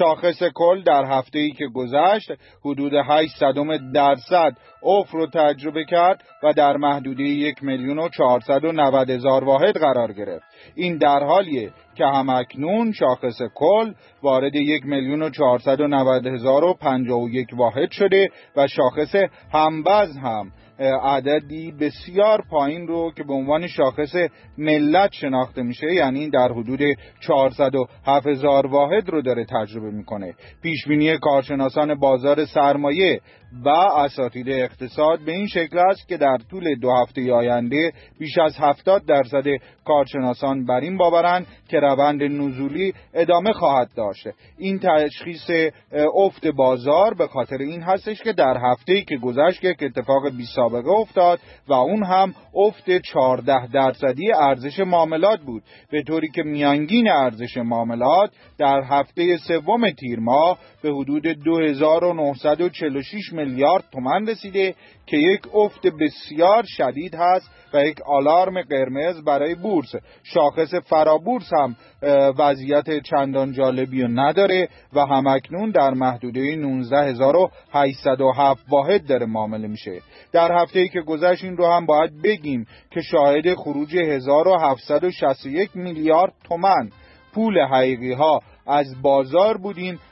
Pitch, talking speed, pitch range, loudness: 145 Hz, 125 wpm, 135-175 Hz, -20 LUFS